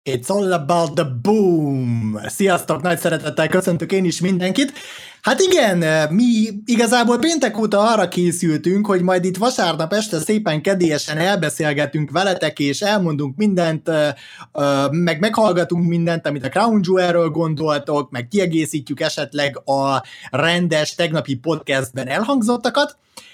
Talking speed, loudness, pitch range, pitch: 125 wpm, -18 LUFS, 150-200 Hz, 170 Hz